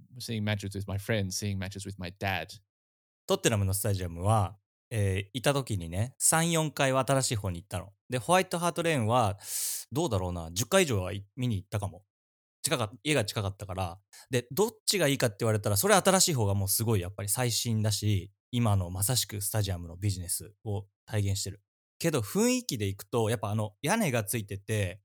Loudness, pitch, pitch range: -29 LUFS, 105 Hz, 100-125 Hz